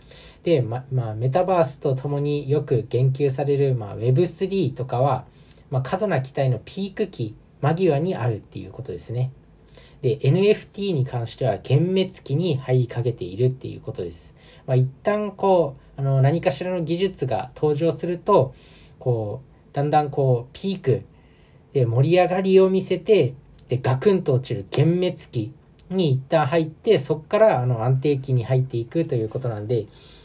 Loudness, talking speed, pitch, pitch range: -22 LUFS, 315 characters per minute, 140 Hz, 125-170 Hz